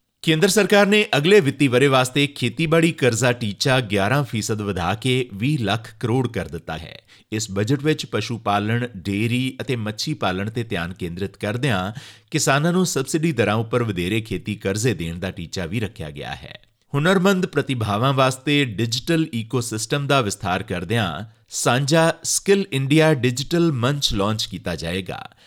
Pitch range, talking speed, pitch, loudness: 100-145 Hz, 150 wpm, 120 Hz, -21 LUFS